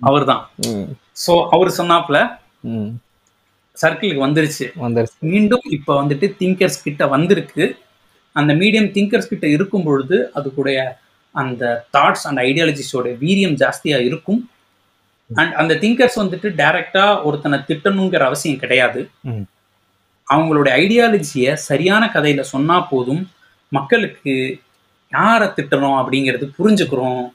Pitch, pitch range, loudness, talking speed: 150 Hz, 130-185 Hz, -16 LUFS, 105 wpm